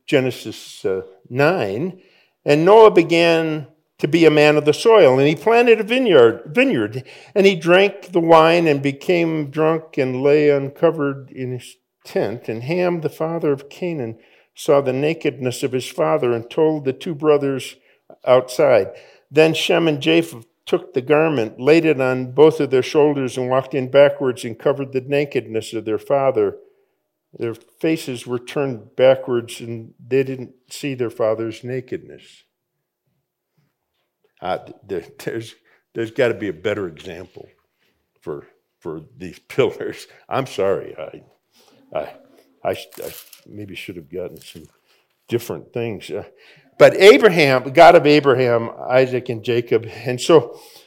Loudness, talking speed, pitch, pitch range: -17 LUFS, 150 wpm, 145 Hz, 125-170 Hz